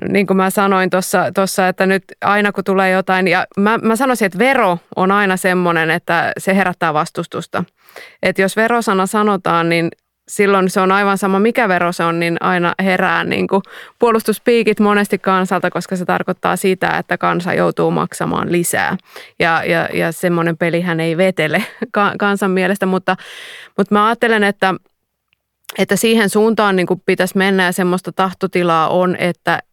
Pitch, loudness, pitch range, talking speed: 190 Hz, -15 LUFS, 180-200 Hz, 160 wpm